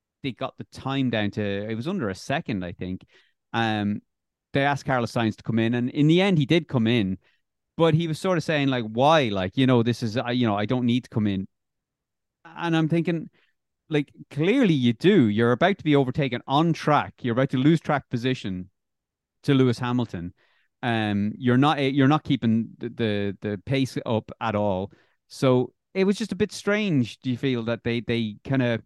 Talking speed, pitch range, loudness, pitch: 210 wpm, 110-145 Hz, -24 LUFS, 125 Hz